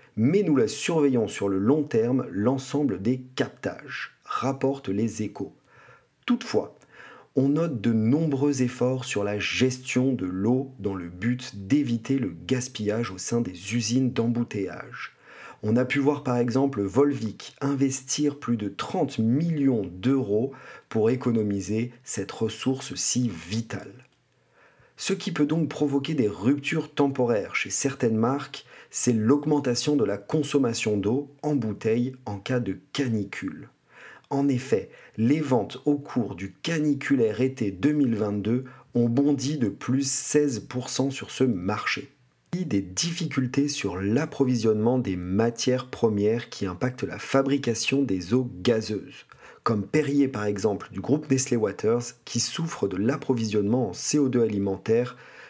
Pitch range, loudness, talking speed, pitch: 110-140 Hz, -26 LUFS, 135 wpm, 125 Hz